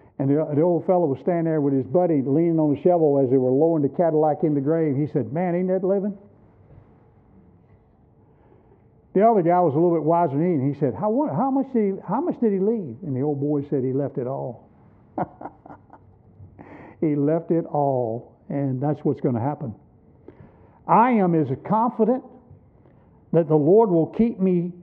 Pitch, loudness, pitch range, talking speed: 165 Hz, -22 LUFS, 145-185 Hz, 200 wpm